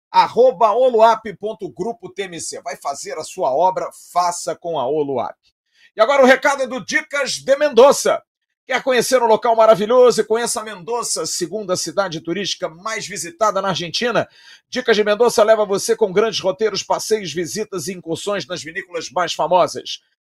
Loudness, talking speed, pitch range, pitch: -18 LUFS, 150 wpm, 180-240 Hz, 215 Hz